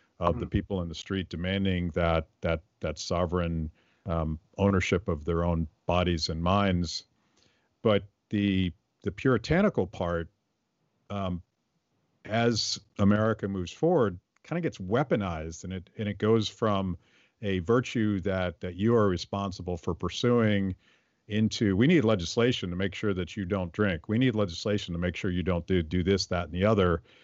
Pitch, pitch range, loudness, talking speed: 95 Hz, 90-105 Hz, -29 LUFS, 165 wpm